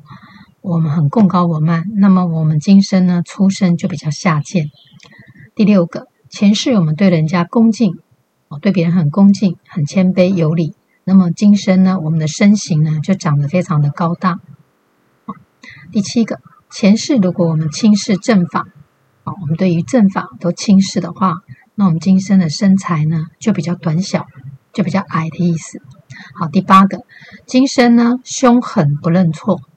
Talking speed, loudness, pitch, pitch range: 245 characters per minute, -14 LUFS, 180 Hz, 160-195 Hz